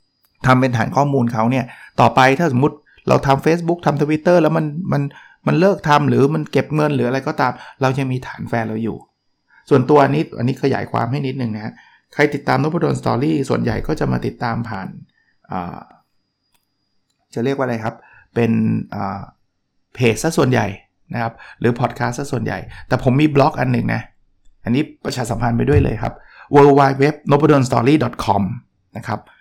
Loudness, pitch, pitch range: -17 LUFS, 135 Hz, 125-150 Hz